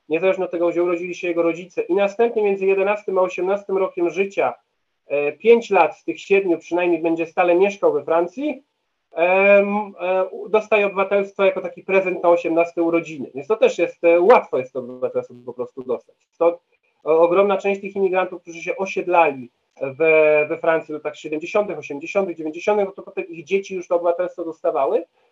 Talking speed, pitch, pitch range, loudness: 170 wpm, 185 Hz, 170-205 Hz, -20 LUFS